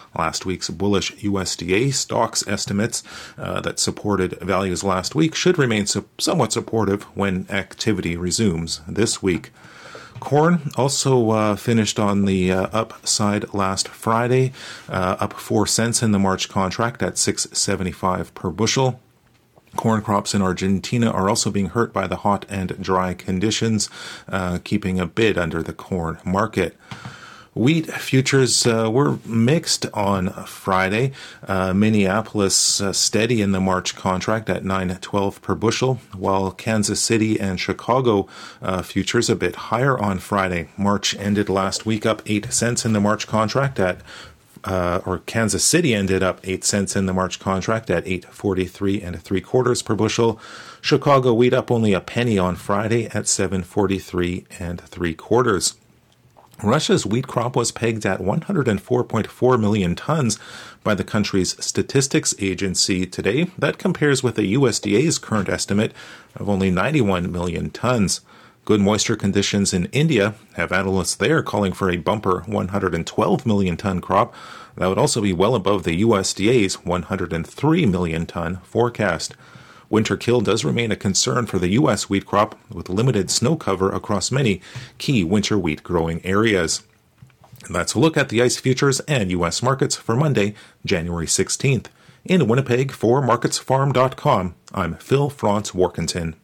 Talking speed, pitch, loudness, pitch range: 150 wpm, 100 Hz, -20 LUFS, 95-115 Hz